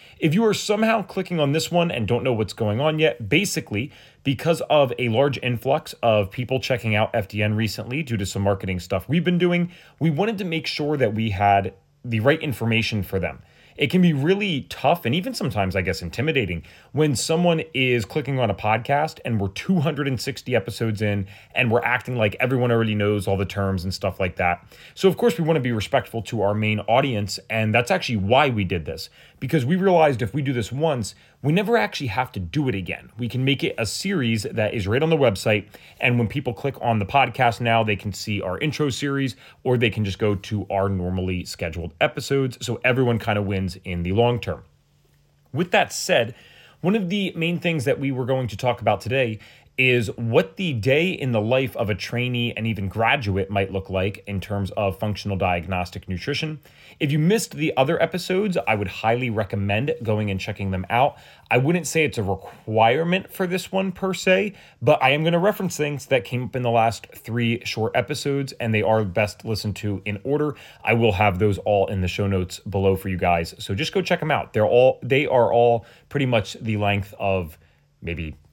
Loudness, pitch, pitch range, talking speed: -22 LUFS, 120 Hz, 100-145 Hz, 215 wpm